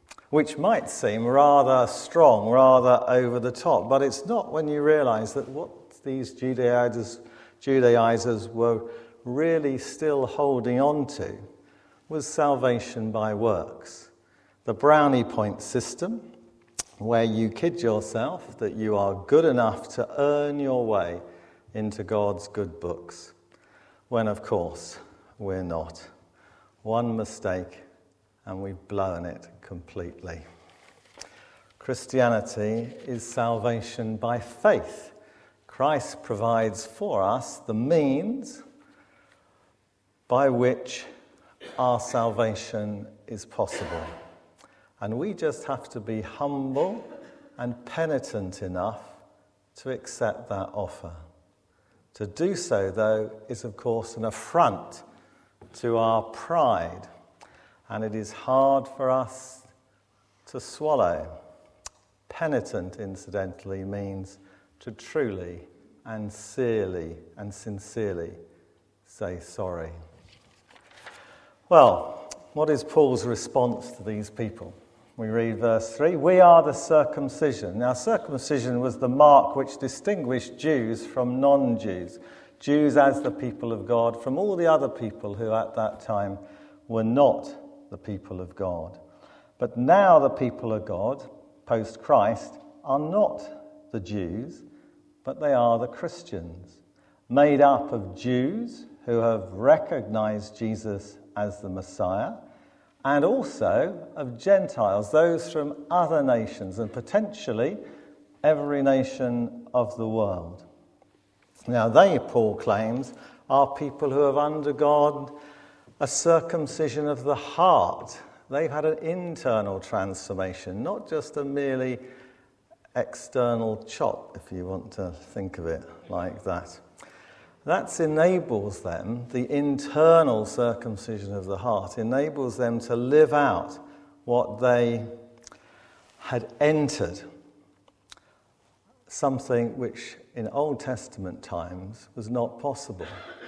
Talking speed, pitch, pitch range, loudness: 115 wpm, 120 Hz, 105-140 Hz, -25 LUFS